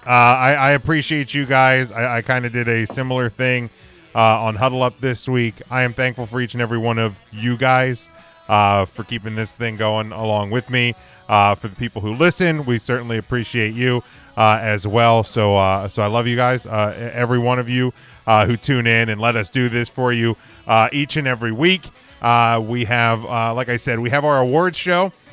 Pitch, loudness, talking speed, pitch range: 120 Hz, -18 LUFS, 220 wpm, 110-130 Hz